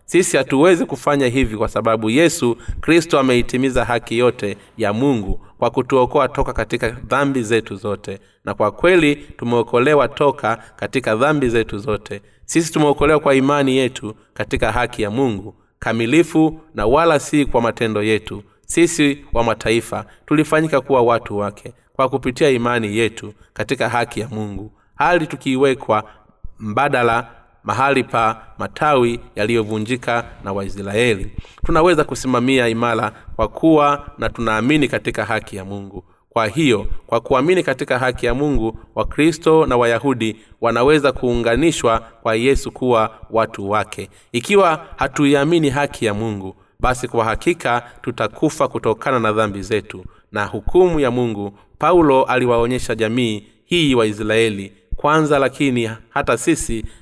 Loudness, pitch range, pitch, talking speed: -17 LUFS, 110-135 Hz, 120 Hz, 130 wpm